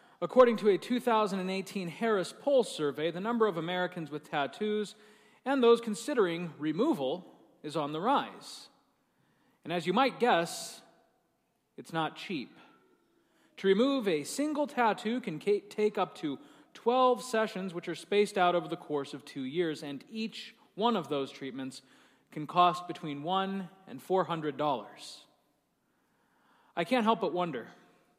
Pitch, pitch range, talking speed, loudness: 190 Hz, 170-230 Hz, 145 wpm, -31 LUFS